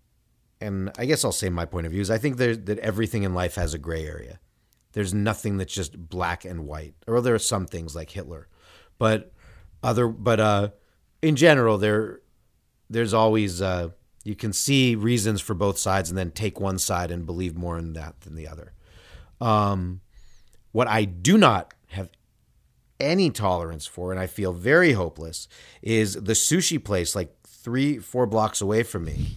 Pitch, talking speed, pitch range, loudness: 100 Hz, 180 wpm, 90-110 Hz, -24 LUFS